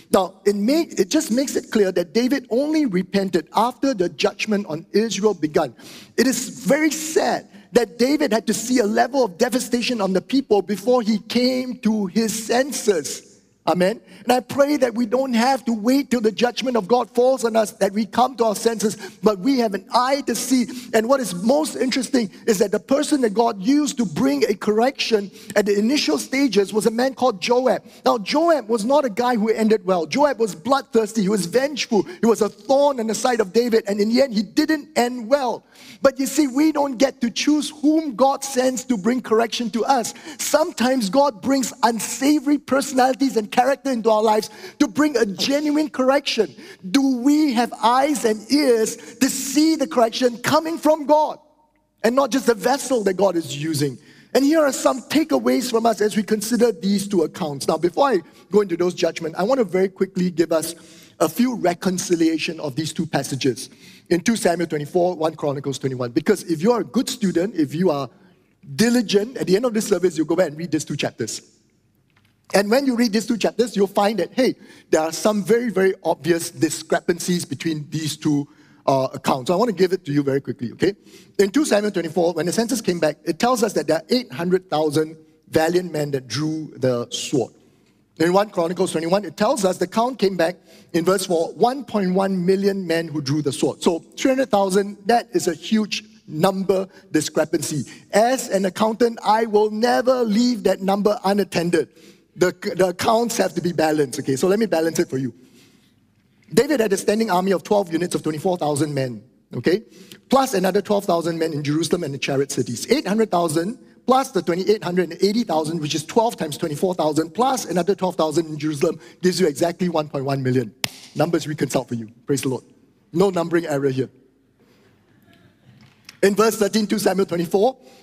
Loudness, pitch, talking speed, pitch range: -20 LUFS, 210 Hz, 195 wpm, 170-245 Hz